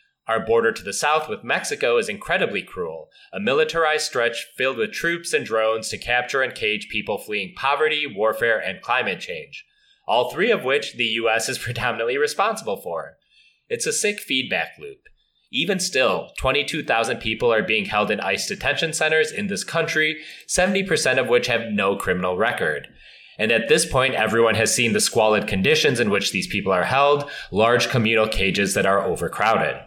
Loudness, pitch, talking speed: -21 LUFS, 155 Hz, 175 wpm